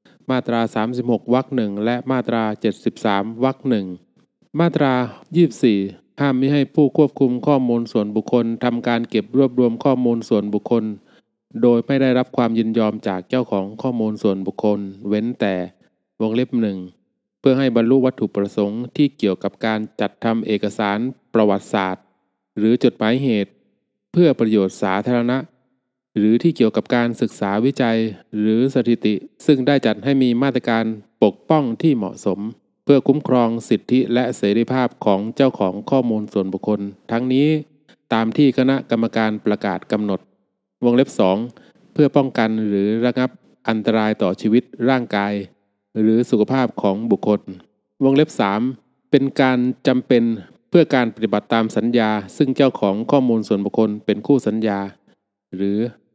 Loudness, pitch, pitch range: -19 LUFS, 115 Hz, 105-130 Hz